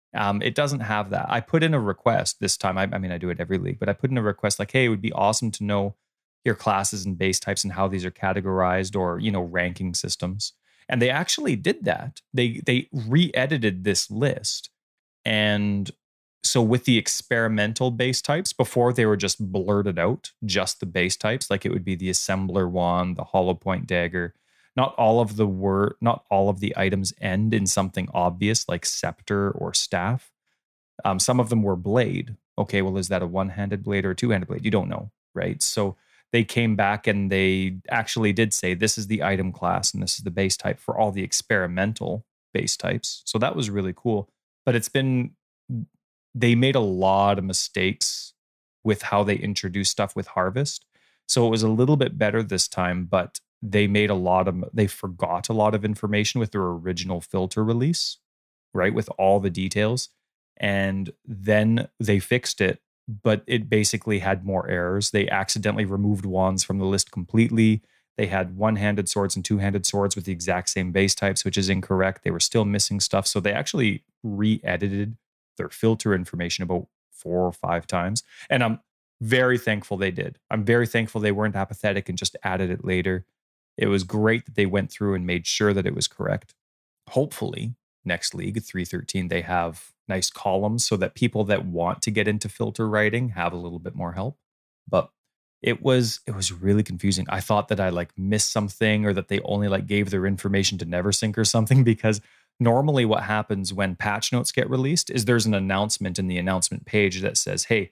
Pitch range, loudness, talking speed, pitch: 95-110 Hz, -24 LUFS, 200 wpm, 100 Hz